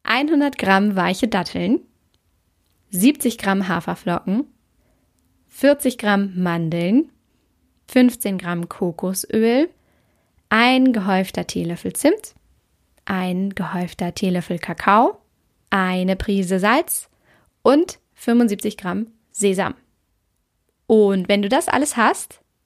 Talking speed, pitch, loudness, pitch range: 90 wpm, 200 Hz, -19 LUFS, 185-245 Hz